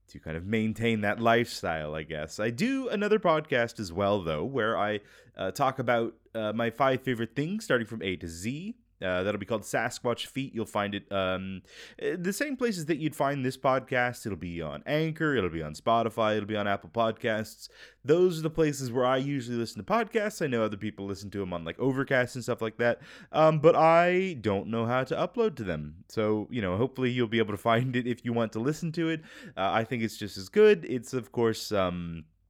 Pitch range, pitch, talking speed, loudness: 100-140 Hz, 115 Hz, 225 wpm, -29 LUFS